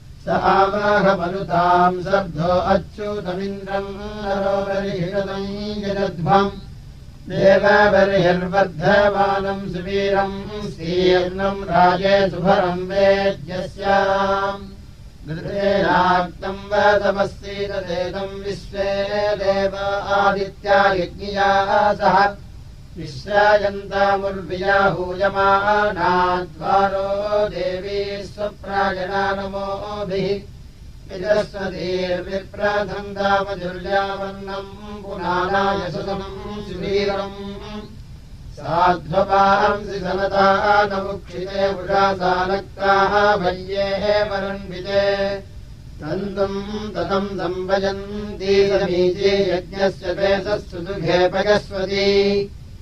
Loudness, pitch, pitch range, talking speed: -19 LUFS, 195 Hz, 185-200 Hz, 40 wpm